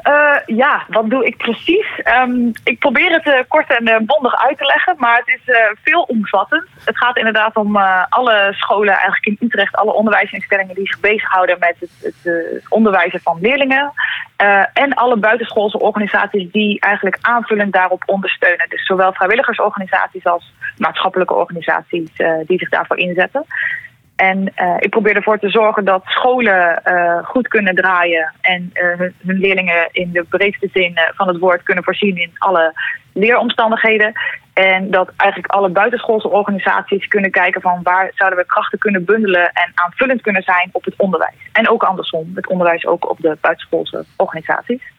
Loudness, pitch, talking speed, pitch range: -14 LUFS, 200 Hz, 170 wpm, 185-225 Hz